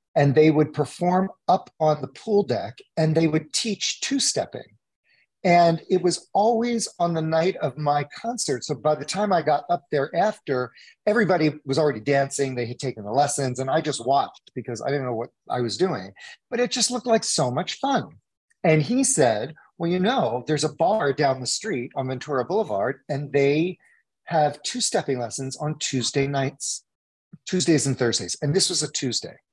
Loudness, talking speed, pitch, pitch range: -23 LUFS, 195 wpm, 150 Hz, 135-180 Hz